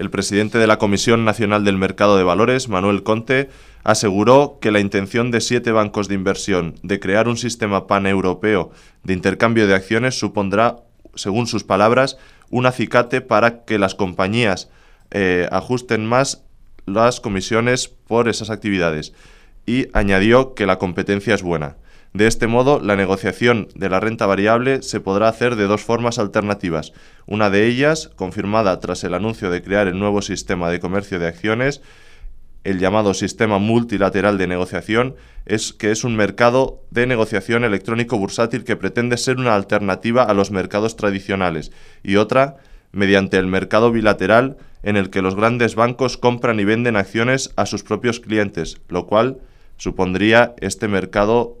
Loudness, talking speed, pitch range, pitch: -18 LUFS, 160 wpm, 95-120 Hz, 105 Hz